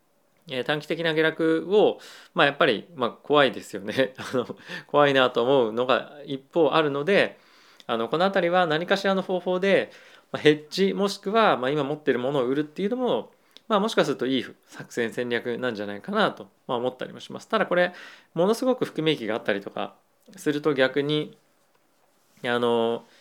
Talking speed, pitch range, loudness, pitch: 355 characters per minute, 130-195 Hz, -24 LUFS, 155 Hz